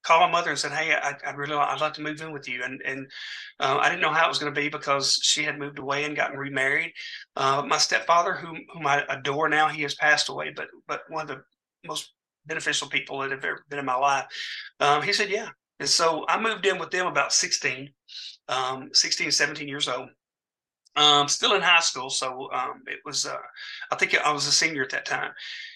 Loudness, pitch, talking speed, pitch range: -24 LUFS, 145 Hz, 240 wpm, 140-155 Hz